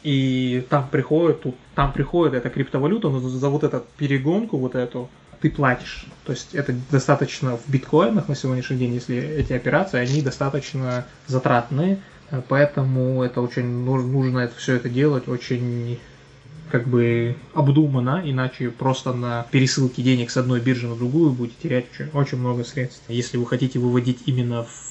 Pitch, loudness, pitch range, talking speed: 130 Hz, -22 LUFS, 125-145 Hz, 160 wpm